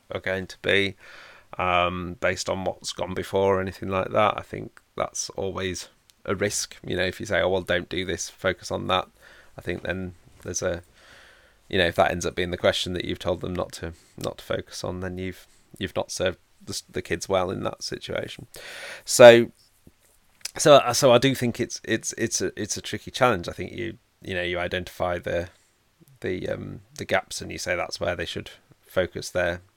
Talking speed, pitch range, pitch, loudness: 210 wpm, 90-115 Hz, 95 Hz, -24 LUFS